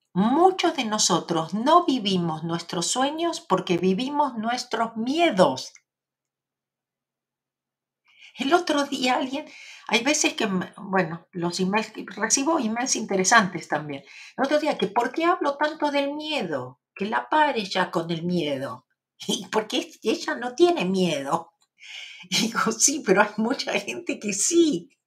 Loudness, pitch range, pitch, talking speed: -23 LUFS, 185-295 Hz, 225 Hz, 135 wpm